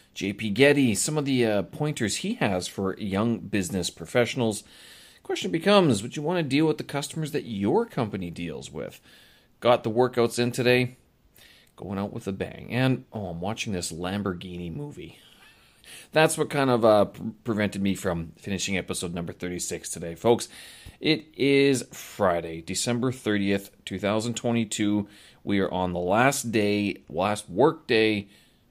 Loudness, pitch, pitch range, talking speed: -26 LUFS, 110 Hz, 95-130 Hz, 155 wpm